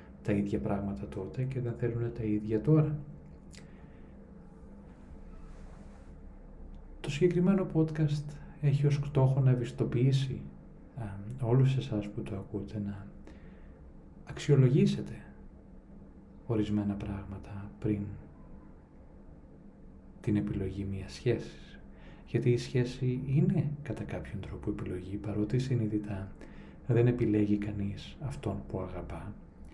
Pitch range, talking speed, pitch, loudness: 100-130 Hz, 95 wpm, 105 Hz, -32 LUFS